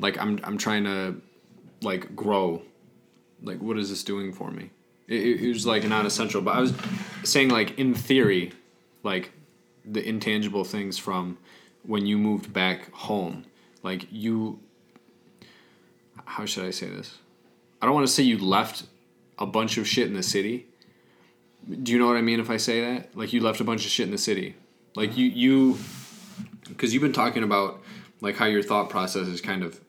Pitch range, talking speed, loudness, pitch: 100-120 Hz, 190 wpm, -25 LUFS, 110 Hz